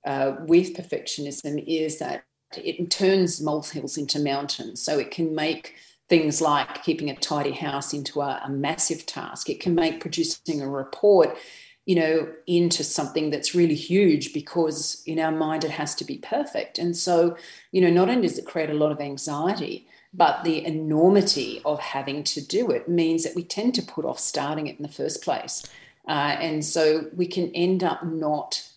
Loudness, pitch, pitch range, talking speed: -24 LUFS, 160 Hz, 150-170 Hz, 185 wpm